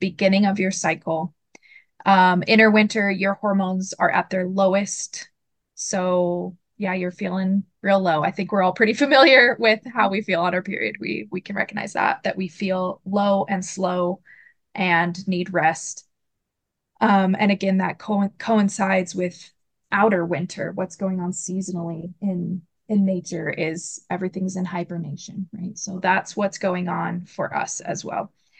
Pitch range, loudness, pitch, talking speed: 180-200 Hz, -21 LUFS, 190 Hz, 160 wpm